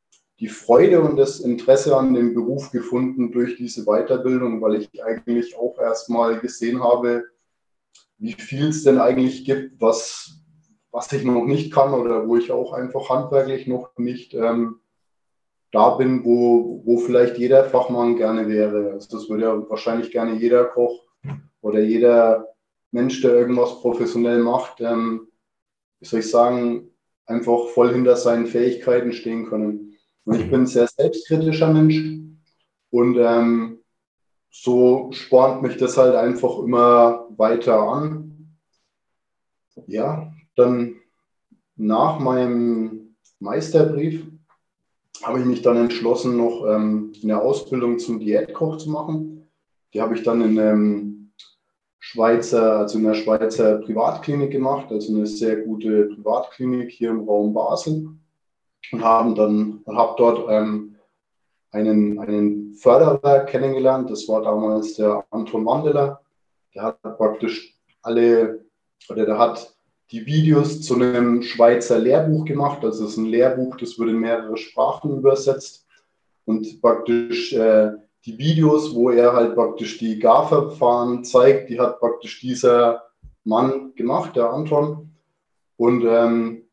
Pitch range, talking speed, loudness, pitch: 115-130 Hz, 135 wpm, -19 LUFS, 120 Hz